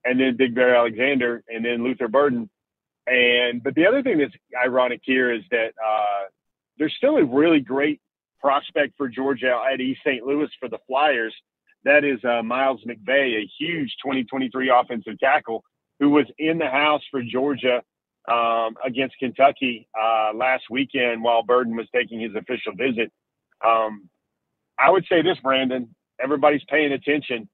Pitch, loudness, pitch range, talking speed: 130 Hz, -21 LUFS, 120-140 Hz, 160 wpm